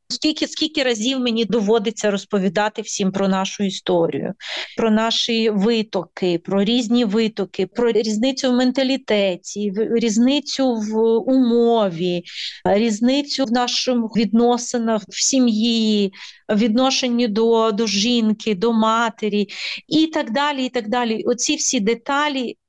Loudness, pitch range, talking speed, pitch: -19 LUFS, 210-250 Hz, 120 wpm, 230 Hz